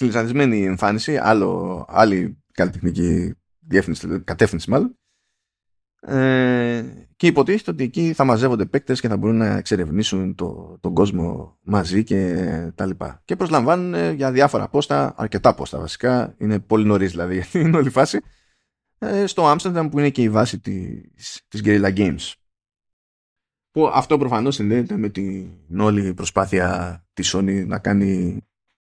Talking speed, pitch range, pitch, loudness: 145 wpm, 95-130 Hz, 105 Hz, -20 LUFS